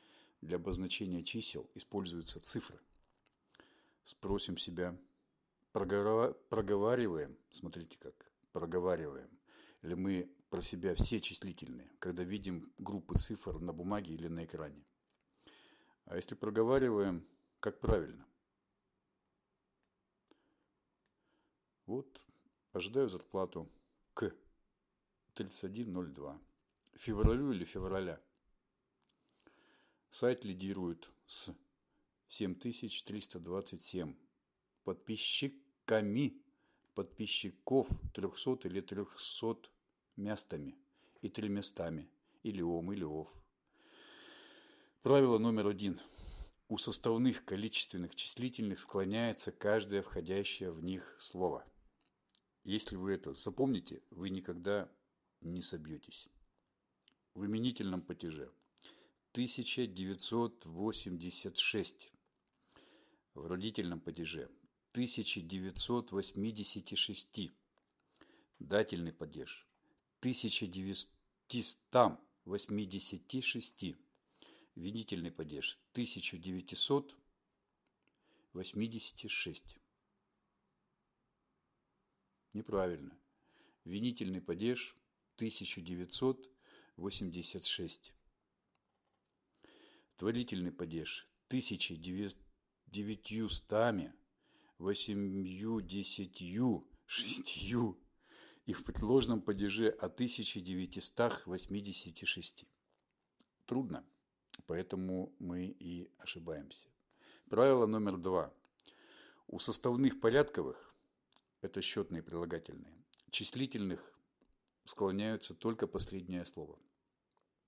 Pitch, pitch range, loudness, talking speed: 100 Hz, 90-110 Hz, -38 LUFS, 65 wpm